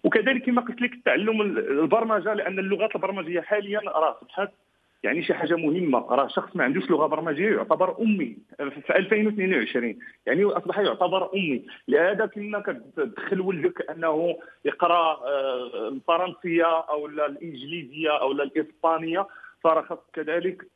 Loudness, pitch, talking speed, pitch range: -25 LUFS, 180 Hz, 125 wpm, 160-205 Hz